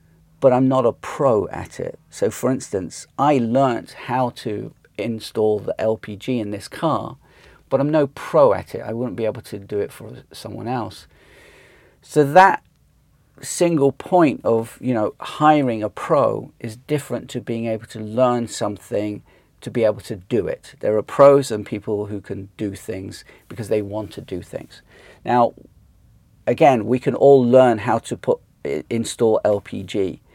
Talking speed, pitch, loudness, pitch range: 170 wpm, 115 Hz, -20 LUFS, 105-130 Hz